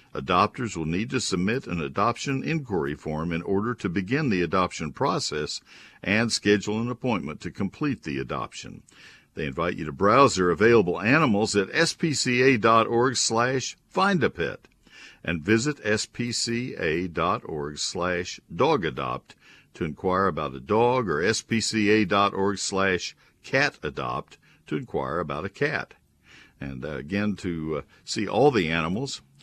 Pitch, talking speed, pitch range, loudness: 105 Hz, 135 wpm, 90-120 Hz, -25 LUFS